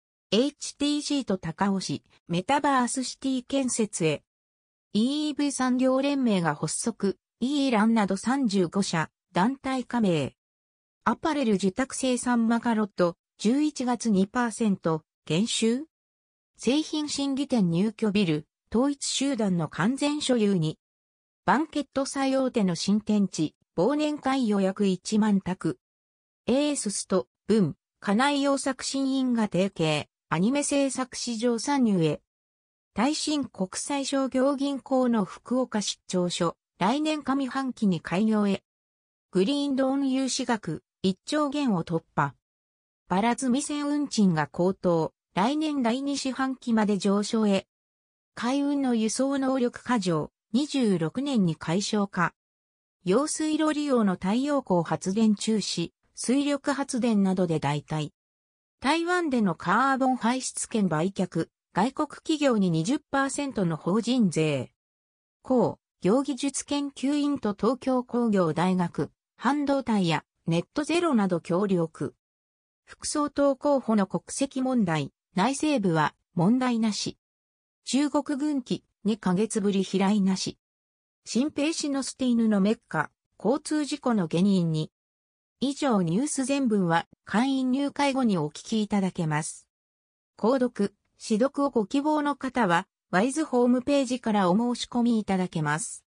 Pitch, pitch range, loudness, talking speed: 220 Hz, 175-270 Hz, -26 LUFS, 230 characters per minute